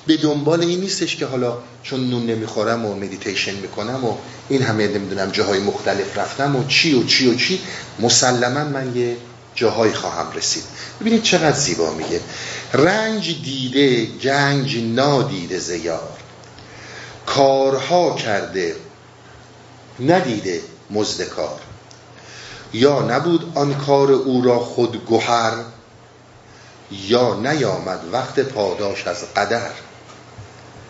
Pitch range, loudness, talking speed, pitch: 115-140 Hz, -19 LUFS, 115 wpm, 125 Hz